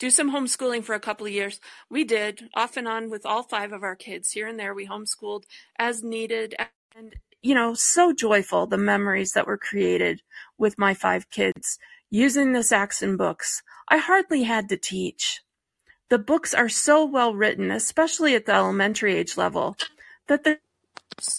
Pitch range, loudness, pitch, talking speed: 210-280 Hz, -23 LUFS, 230 Hz, 175 wpm